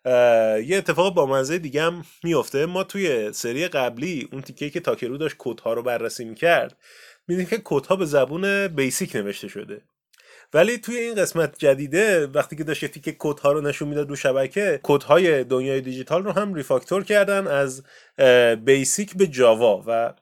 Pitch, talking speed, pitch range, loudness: 150 Hz, 165 wpm, 130-185 Hz, -21 LUFS